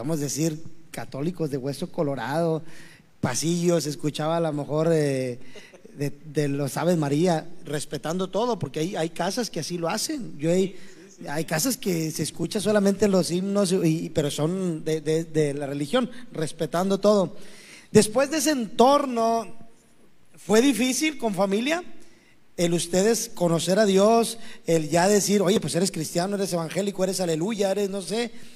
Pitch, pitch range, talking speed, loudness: 175 Hz, 160-205 Hz, 160 wpm, -24 LUFS